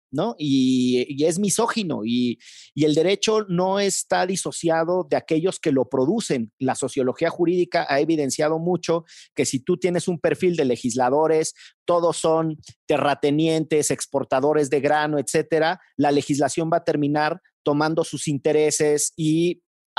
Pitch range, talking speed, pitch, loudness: 145-170 Hz, 140 wpm, 155 Hz, -22 LUFS